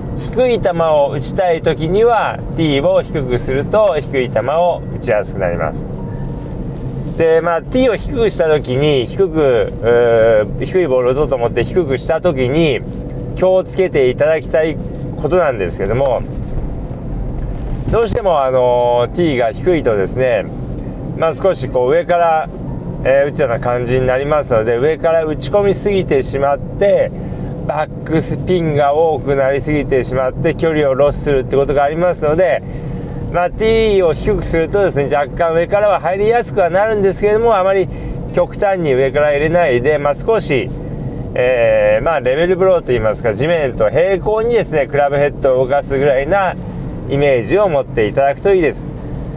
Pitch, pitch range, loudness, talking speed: 155 Hz, 135-180 Hz, -15 LUFS, 345 characters per minute